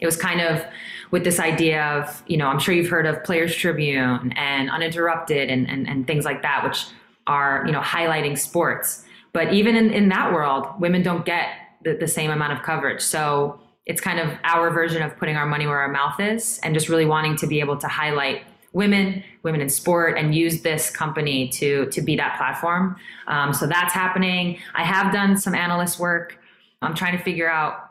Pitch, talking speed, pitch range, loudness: 165 Hz, 210 wpm, 145-175 Hz, -21 LUFS